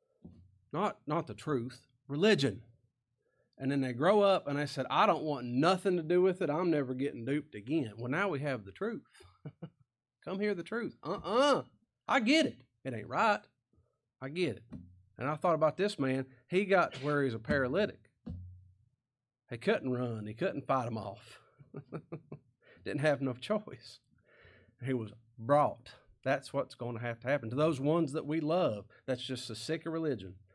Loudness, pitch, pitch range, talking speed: -33 LUFS, 135 Hz, 120-165 Hz, 185 wpm